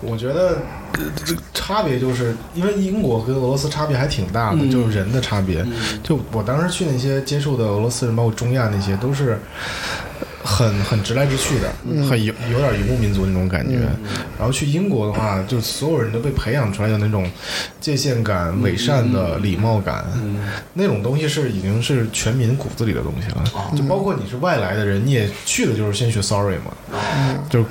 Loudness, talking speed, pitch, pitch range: -20 LUFS, 300 characters per minute, 120 Hz, 105-135 Hz